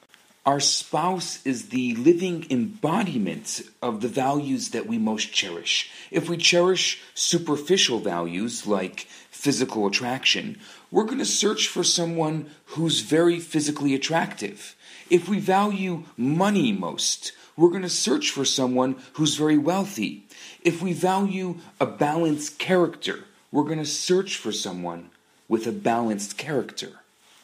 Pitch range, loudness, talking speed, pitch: 130-180 Hz, -24 LUFS, 135 wpm, 155 Hz